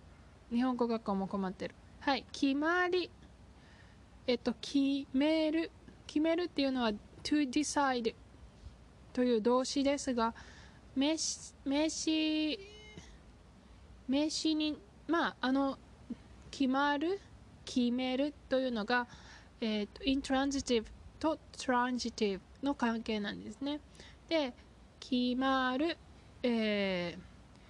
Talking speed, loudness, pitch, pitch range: 235 characters per minute, -34 LUFS, 265 Hz, 240-300 Hz